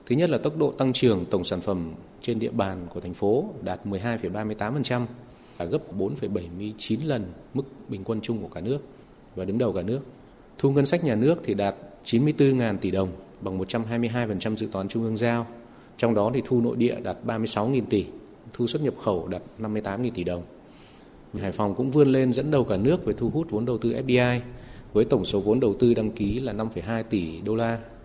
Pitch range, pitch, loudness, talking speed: 100-125 Hz, 115 Hz, -26 LUFS, 210 wpm